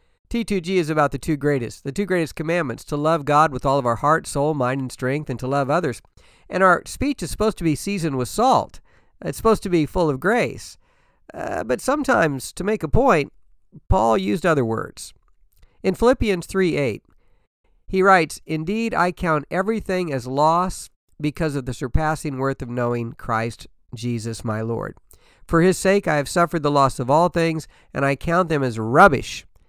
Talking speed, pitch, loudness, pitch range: 190 wpm, 155 Hz, -21 LUFS, 130-185 Hz